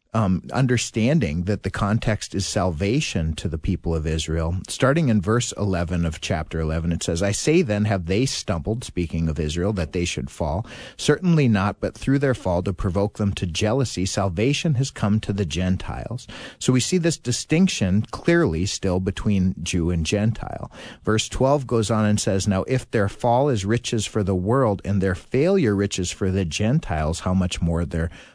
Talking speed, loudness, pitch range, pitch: 185 wpm, -22 LUFS, 90-120 Hz, 100 Hz